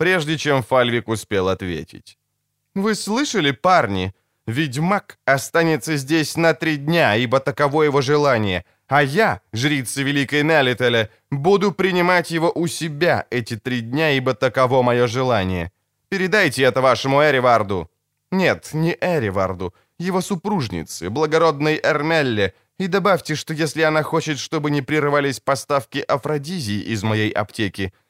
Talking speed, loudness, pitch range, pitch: 130 wpm, -19 LUFS, 115-160 Hz, 140 Hz